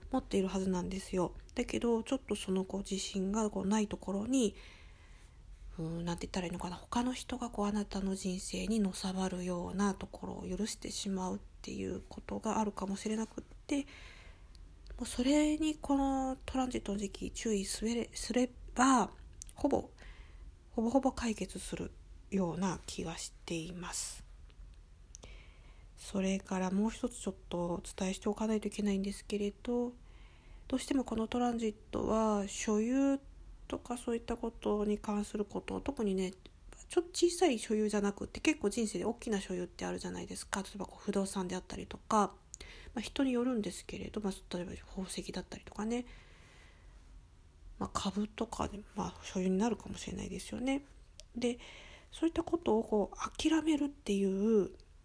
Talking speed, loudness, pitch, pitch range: 350 characters per minute, -36 LUFS, 205 Hz, 190-235 Hz